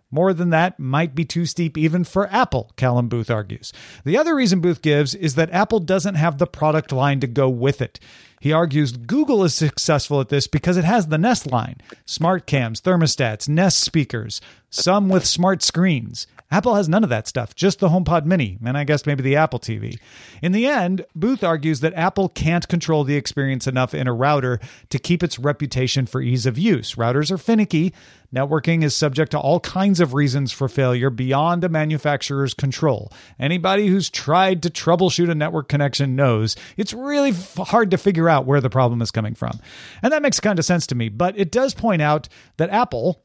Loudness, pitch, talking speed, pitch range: -19 LUFS, 155 Hz, 205 wpm, 130-180 Hz